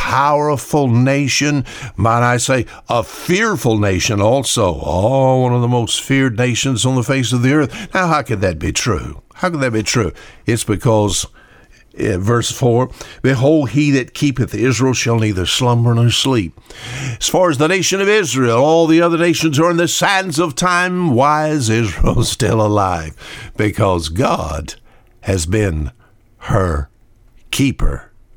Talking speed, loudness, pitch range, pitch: 160 wpm, -15 LUFS, 110-145 Hz, 125 Hz